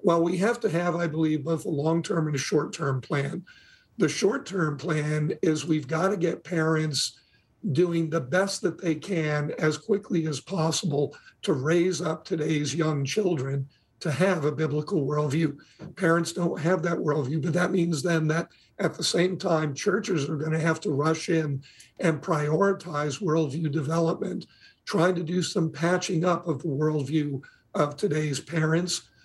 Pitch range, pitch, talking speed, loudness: 150-175 Hz, 160 Hz, 175 wpm, -27 LUFS